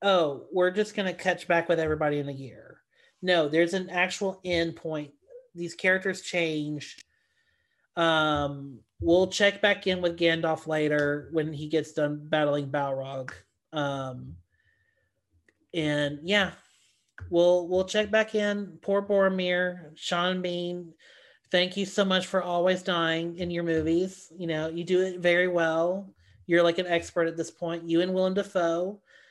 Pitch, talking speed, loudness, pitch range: 170 Hz, 155 wpm, -27 LUFS, 155-185 Hz